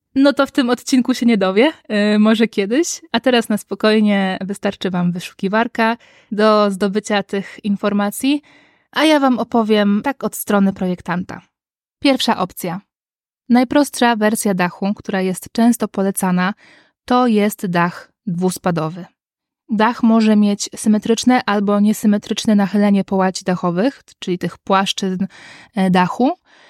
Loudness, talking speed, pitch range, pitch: -17 LUFS, 125 wpm, 195-235 Hz, 210 Hz